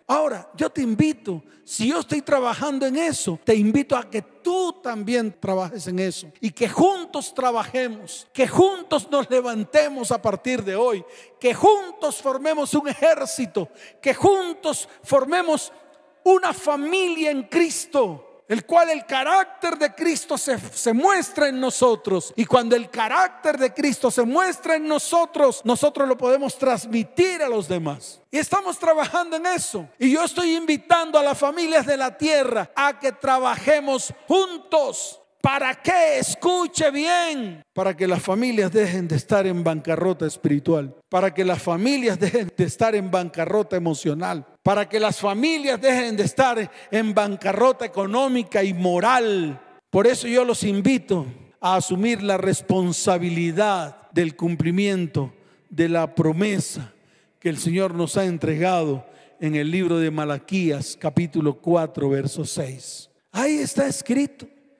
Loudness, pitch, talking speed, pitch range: -21 LUFS, 245 Hz, 145 wpm, 185-295 Hz